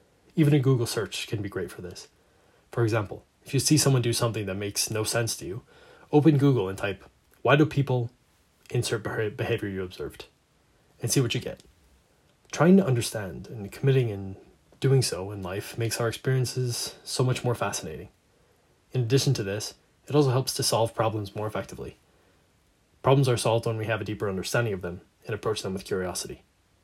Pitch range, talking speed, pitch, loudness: 100-130 Hz, 190 wpm, 115 Hz, -26 LUFS